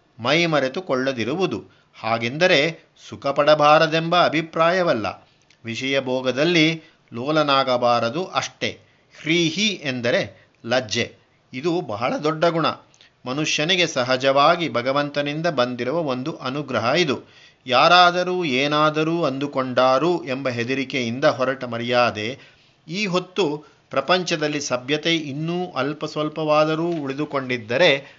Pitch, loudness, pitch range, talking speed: 145 Hz, -20 LUFS, 130-165 Hz, 80 wpm